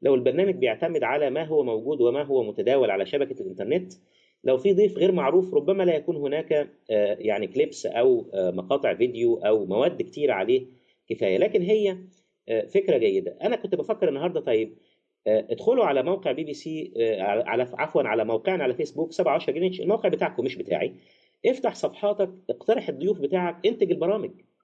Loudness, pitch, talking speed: -25 LUFS, 210 Hz, 175 wpm